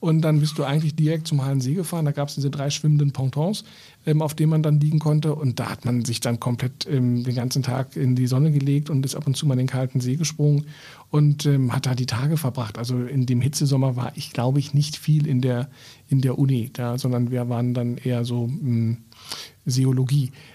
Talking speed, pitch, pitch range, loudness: 235 wpm, 135 Hz, 125-150 Hz, -23 LUFS